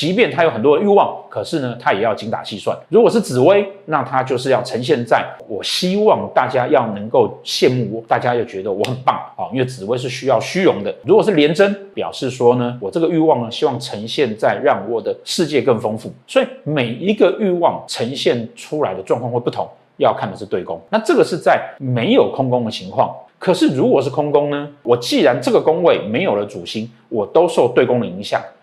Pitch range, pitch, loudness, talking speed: 125-185 Hz, 145 Hz, -17 LUFS, 325 characters per minute